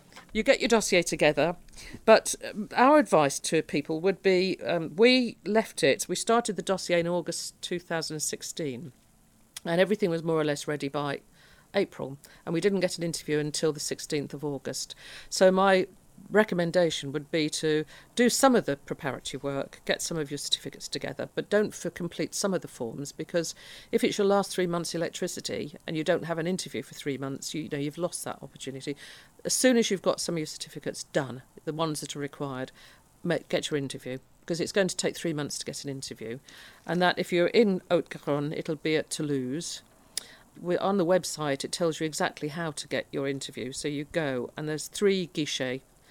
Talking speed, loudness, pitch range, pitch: 200 wpm, -28 LUFS, 145-185 Hz, 160 Hz